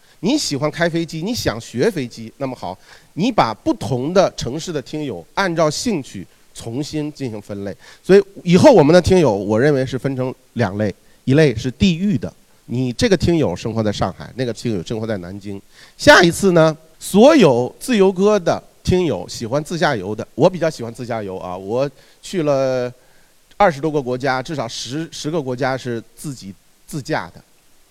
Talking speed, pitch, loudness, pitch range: 270 characters per minute, 140 Hz, -17 LUFS, 115-170 Hz